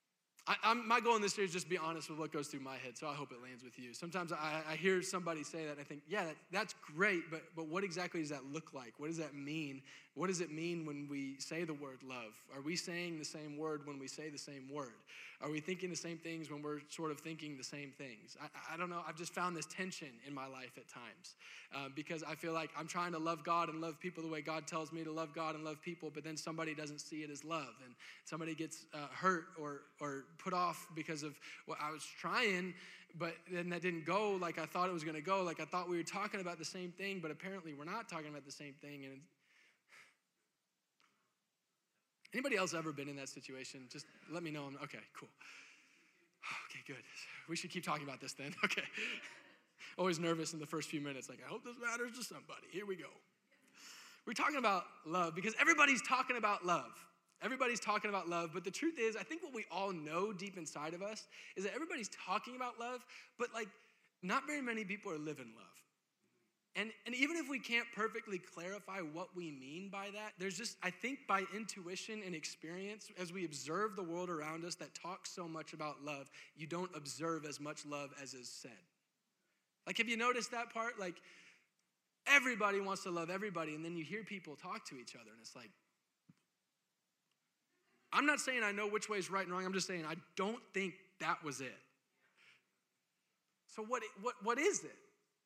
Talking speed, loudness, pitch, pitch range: 225 wpm, -41 LUFS, 170 Hz, 150-200 Hz